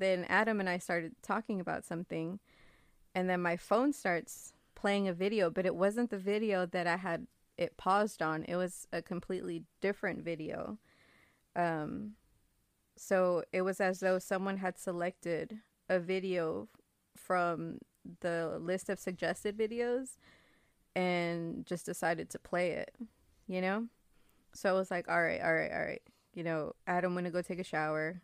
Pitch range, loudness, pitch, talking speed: 170-200 Hz, -35 LUFS, 185 Hz, 160 wpm